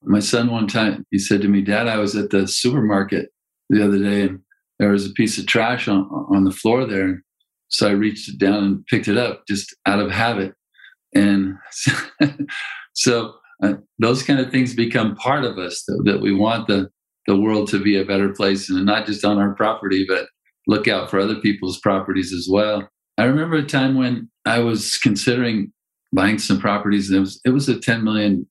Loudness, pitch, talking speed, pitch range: -19 LUFS, 105 Hz, 210 wpm, 100-115 Hz